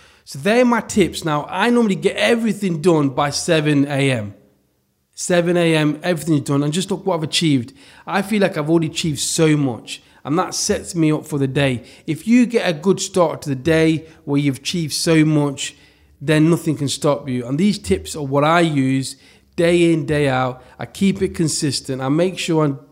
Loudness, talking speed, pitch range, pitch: -18 LUFS, 200 wpm, 140-175 Hz, 155 Hz